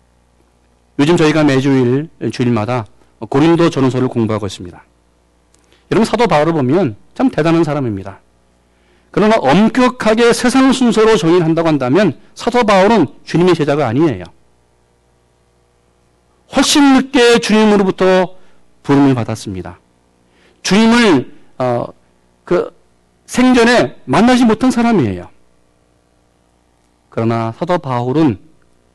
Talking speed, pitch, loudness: 260 characters per minute, 120 Hz, -13 LUFS